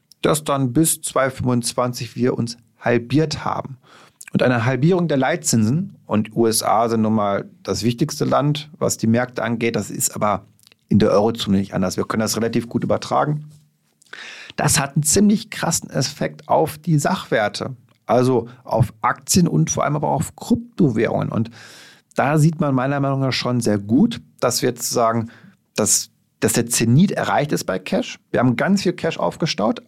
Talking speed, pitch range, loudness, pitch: 175 wpm, 115-155 Hz, -19 LUFS, 125 Hz